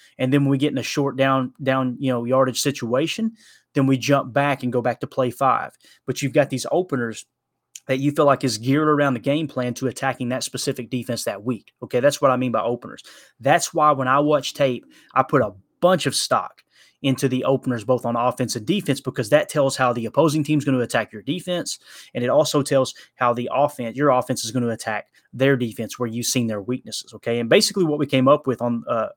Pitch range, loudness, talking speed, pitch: 125-145 Hz, -21 LUFS, 235 wpm, 130 Hz